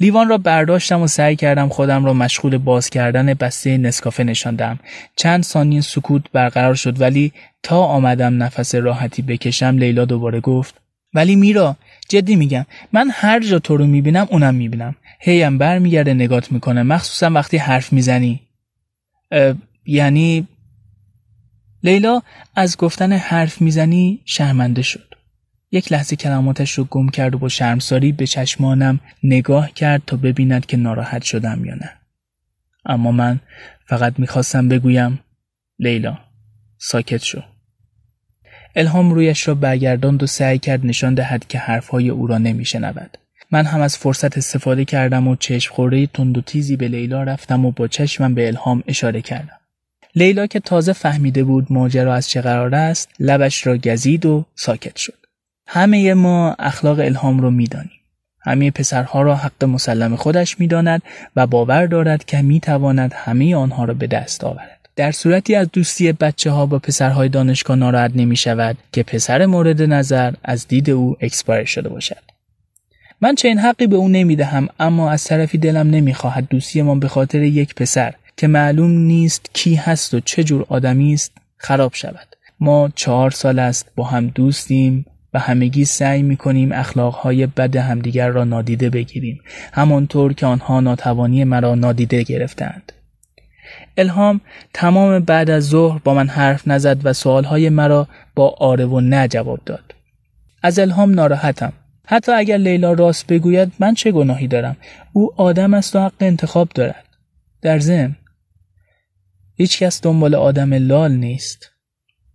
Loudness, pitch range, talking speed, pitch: -15 LUFS, 125-155 Hz, 155 wpm, 135 Hz